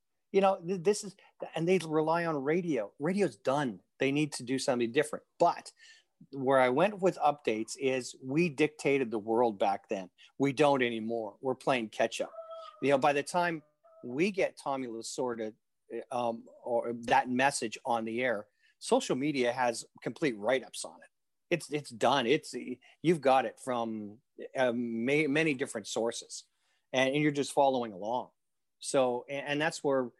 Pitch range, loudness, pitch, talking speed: 120-160 Hz, -31 LUFS, 140 Hz, 165 wpm